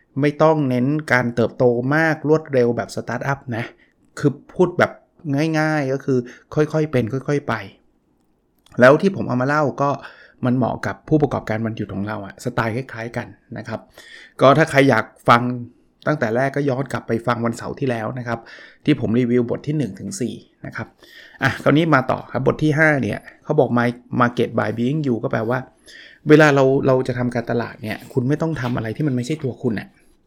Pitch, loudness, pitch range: 125 Hz, -19 LUFS, 115-145 Hz